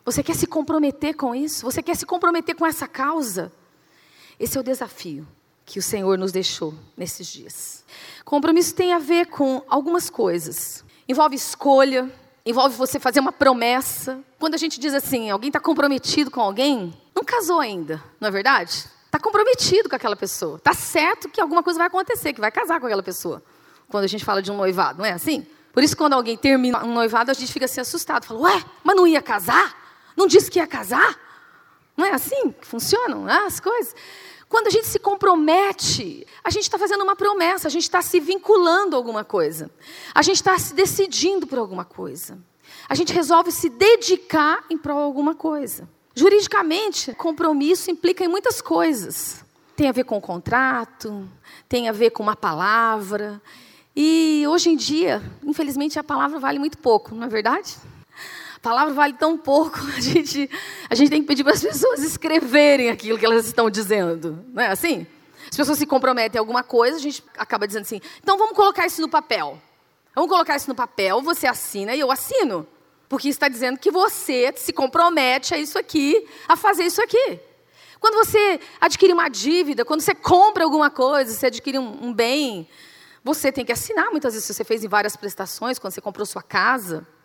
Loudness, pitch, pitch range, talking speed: -20 LUFS, 290 Hz, 235-345 Hz, 190 wpm